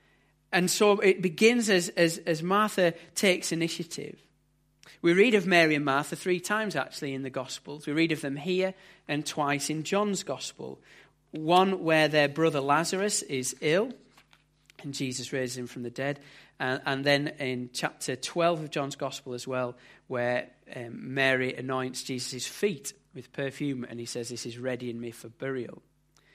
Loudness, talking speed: -28 LUFS, 170 wpm